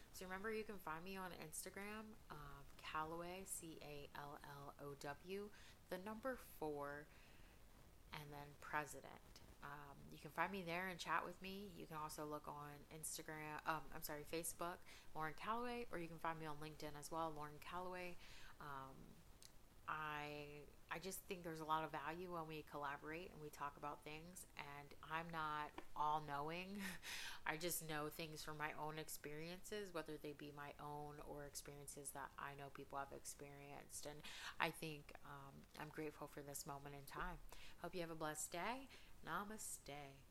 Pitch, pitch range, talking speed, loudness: 155 Hz, 145-175 Hz, 175 wpm, -51 LUFS